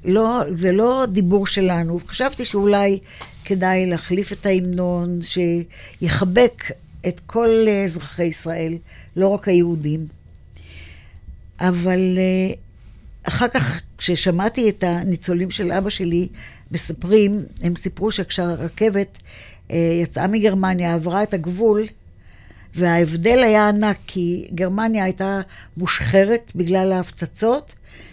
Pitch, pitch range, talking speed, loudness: 185 Hz, 170-200 Hz, 100 wpm, -19 LUFS